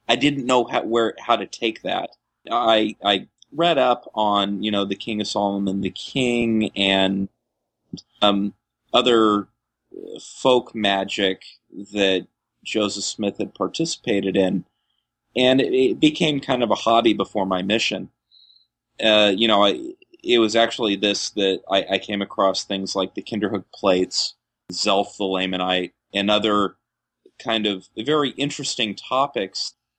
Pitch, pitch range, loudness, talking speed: 105 Hz, 100-120 Hz, -21 LUFS, 145 wpm